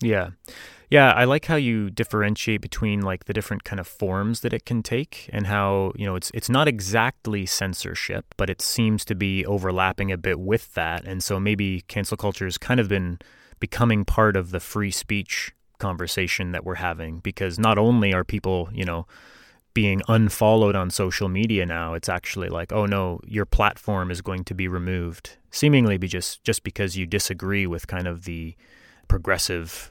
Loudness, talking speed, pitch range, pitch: -23 LUFS, 185 wpm, 90-110 Hz, 100 Hz